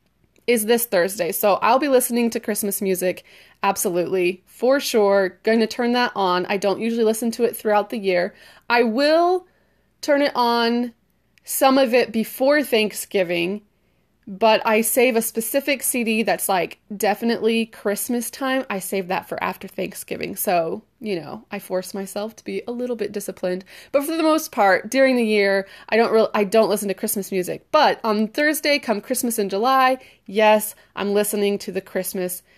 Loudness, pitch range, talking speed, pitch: -20 LUFS, 195-245 Hz, 175 wpm, 220 Hz